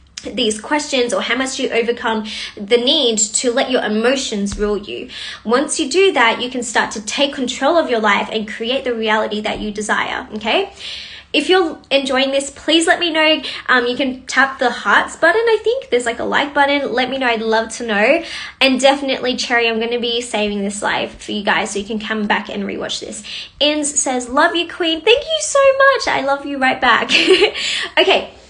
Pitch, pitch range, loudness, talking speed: 255 Hz, 225-290 Hz, -16 LUFS, 210 wpm